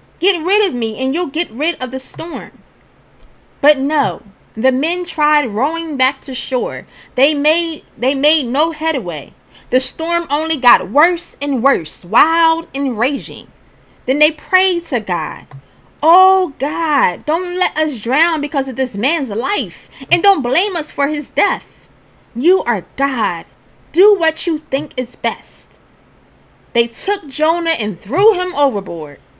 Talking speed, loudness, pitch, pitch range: 155 wpm, -15 LUFS, 300 Hz, 260-335 Hz